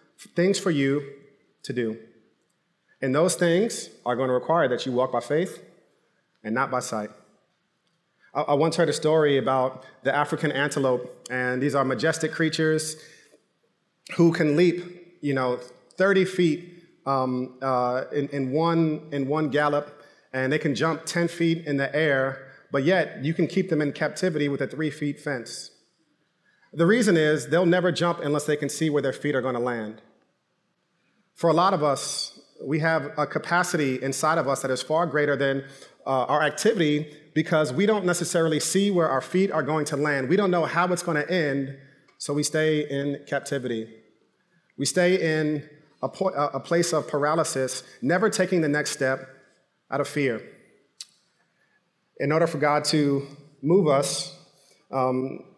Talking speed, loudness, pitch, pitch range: 170 wpm, -24 LUFS, 150 Hz, 135-165 Hz